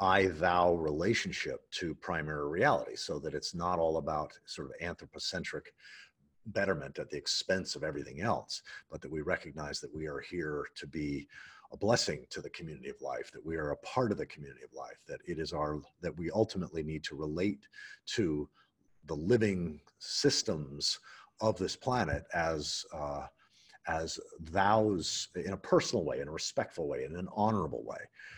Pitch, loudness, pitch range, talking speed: 80 Hz, -34 LUFS, 75-95 Hz, 175 wpm